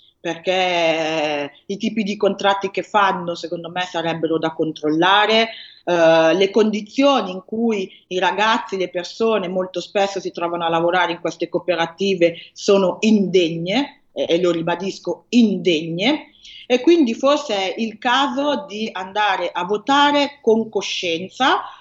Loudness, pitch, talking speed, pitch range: -19 LUFS, 190 Hz, 130 wpm, 175-220 Hz